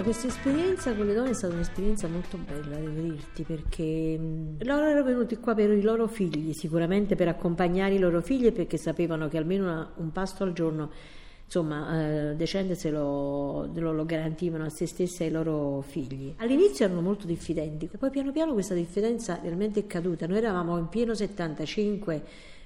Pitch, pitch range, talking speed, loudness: 175 Hz, 160-205 Hz, 175 wpm, -29 LUFS